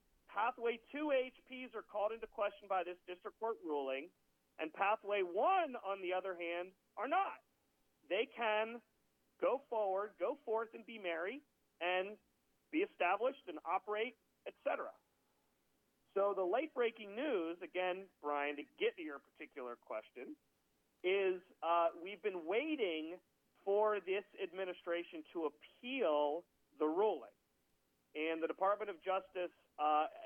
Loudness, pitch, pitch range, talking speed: -40 LUFS, 195 Hz, 170-235 Hz, 130 wpm